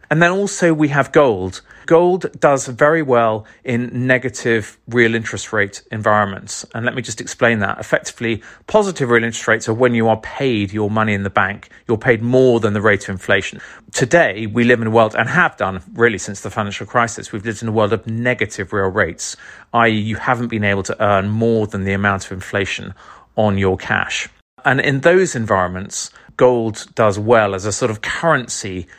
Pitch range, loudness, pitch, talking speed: 105-125 Hz, -17 LUFS, 115 Hz, 200 wpm